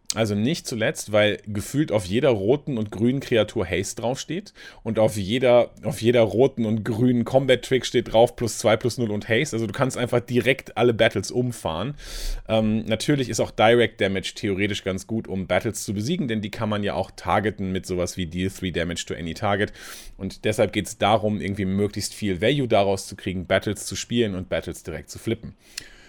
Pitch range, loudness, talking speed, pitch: 100-120 Hz, -23 LUFS, 200 wpm, 110 Hz